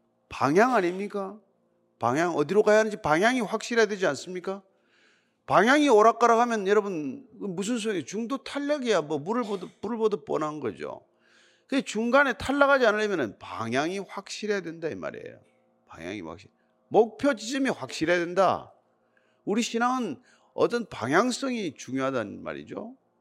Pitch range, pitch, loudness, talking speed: 195-245 Hz, 215 Hz, -26 LUFS, 325 characters per minute